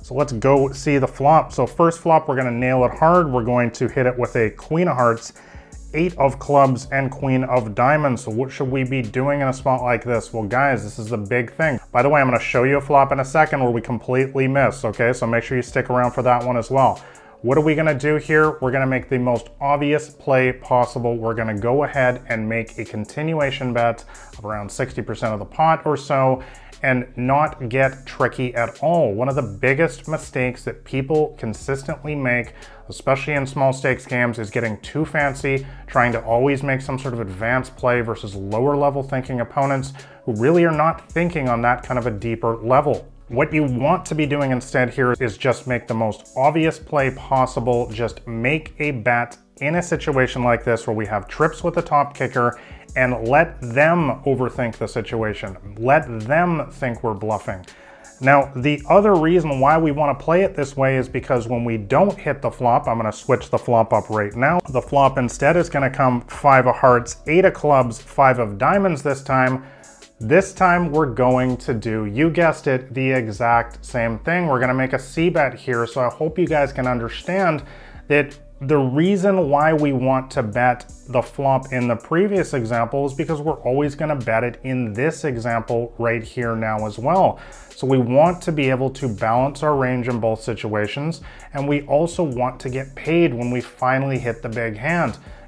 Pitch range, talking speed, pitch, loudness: 120-145 Hz, 210 wpm, 130 Hz, -20 LUFS